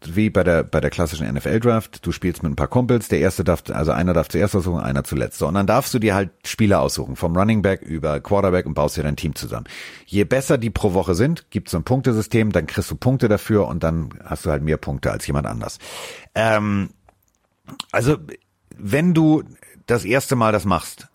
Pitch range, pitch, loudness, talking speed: 80-110 Hz, 100 Hz, -20 LUFS, 215 wpm